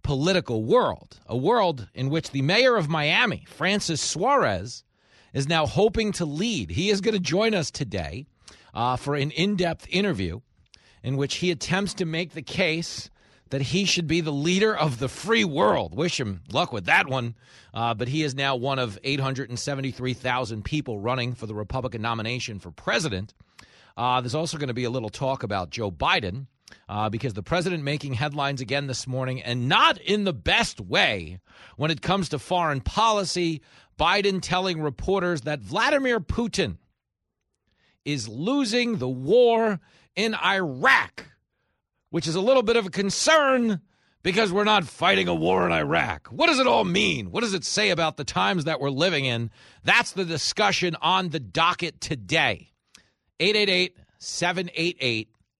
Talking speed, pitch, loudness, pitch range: 170 wpm, 150 Hz, -24 LUFS, 125-185 Hz